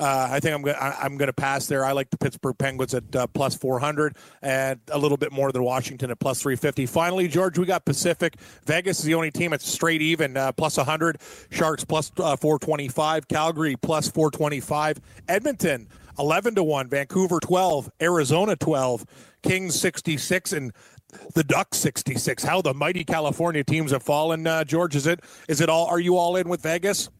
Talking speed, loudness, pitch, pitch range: 190 wpm, -24 LUFS, 155 Hz, 140-165 Hz